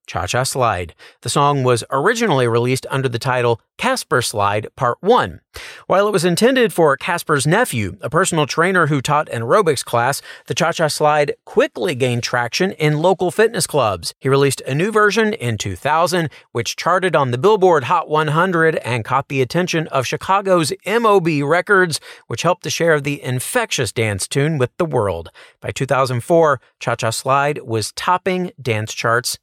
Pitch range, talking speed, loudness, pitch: 125-175 Hz, 170 wpm, -17 LUFS, 145 Hz